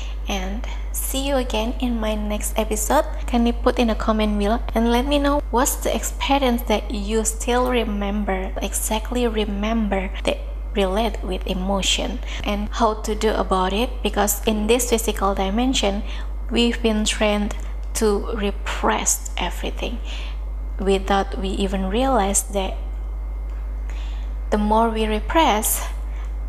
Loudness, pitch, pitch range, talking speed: -22 LUFS, 215 Hz, 195-235 Hz, 130 wpm